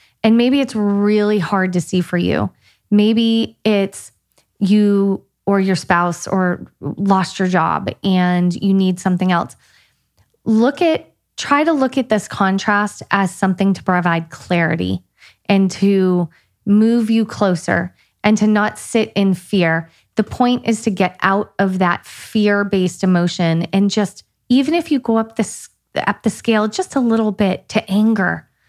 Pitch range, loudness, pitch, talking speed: 180-220 Hz, -17 LUFS, 200 Hz, 160 wpm